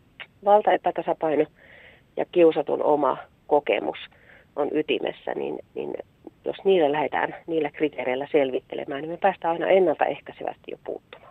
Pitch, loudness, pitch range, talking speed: 165 Hz, -24 LUFS, 150-190 Hz, 120 wpm